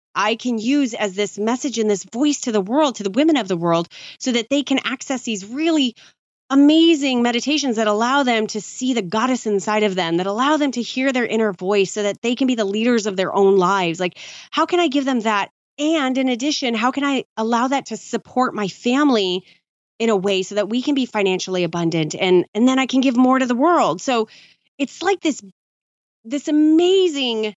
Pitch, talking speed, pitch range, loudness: 240 Hz, 220 wpm, 205-275 Hz, -19 LUFS